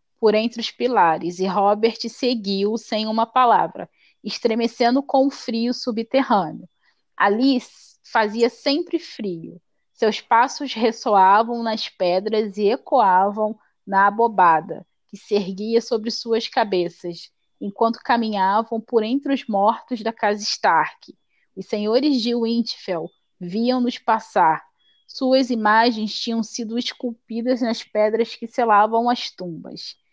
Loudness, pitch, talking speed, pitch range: -20 LUFS, 230 Hz, 120 wpm, 210-240 Hz